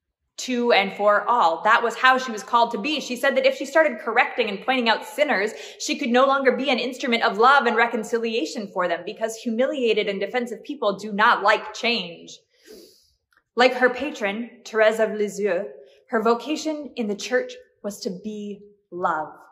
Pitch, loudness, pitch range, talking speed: 235 Hz, -22 LUFS, 210-260 Hz, 185 wpm